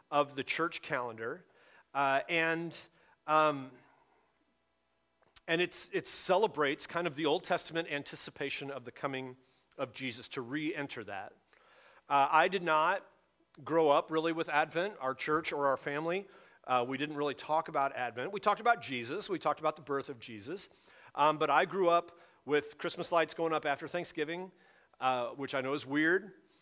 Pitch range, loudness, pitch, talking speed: 135-165 Hz, -33 LUFS, 150 Hz, 170 wpm